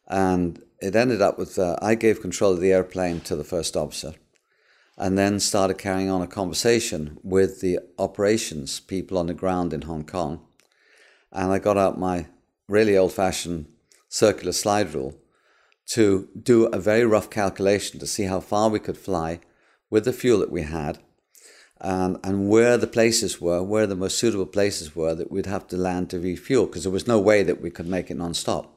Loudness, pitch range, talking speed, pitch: -23 LUFS, 90-105 Hz, 195 wpm, 95 Hz